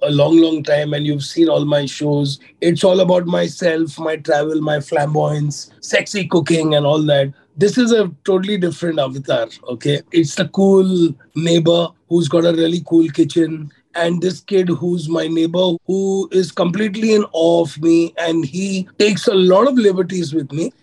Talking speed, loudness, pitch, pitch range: 180 wpm, -16 LUFS, 165 Hz, 150-185 Hz